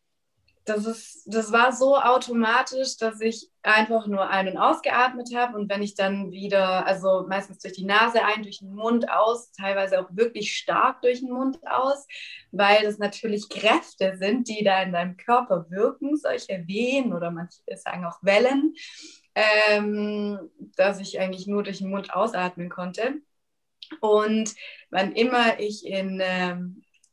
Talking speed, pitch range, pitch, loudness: 155 wpm, 195-240 Hz, 210 Hz, -24 LUFS